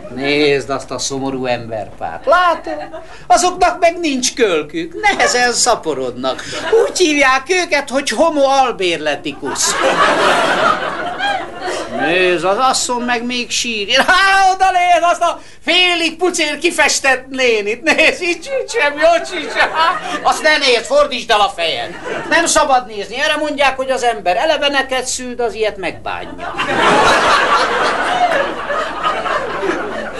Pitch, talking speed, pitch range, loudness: 285 Hz, 115 wpm, 240-345 Hz, -14 LUFS